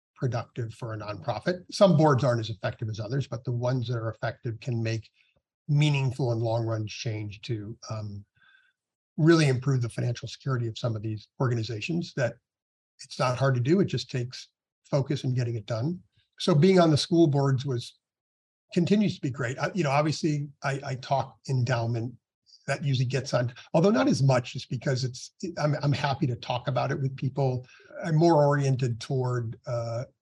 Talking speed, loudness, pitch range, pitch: 185 wpm, -27 LUFS, 115-145 Hz, 130 Hz